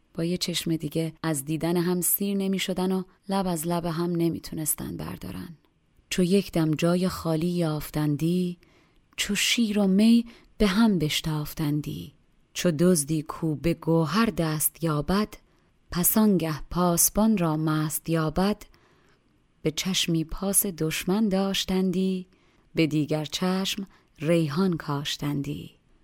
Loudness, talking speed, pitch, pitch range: -25 LUFS, 120 wpm, 170 Hz, 160-190 Hz